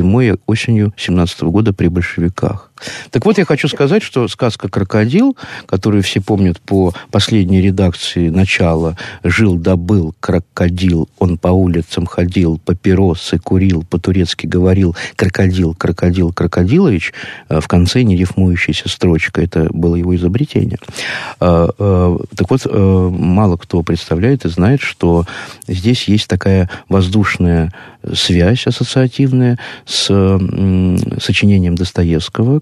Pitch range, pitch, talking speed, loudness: 90-105 Hz, 95 Hz, 115 wpm, -13 LUFS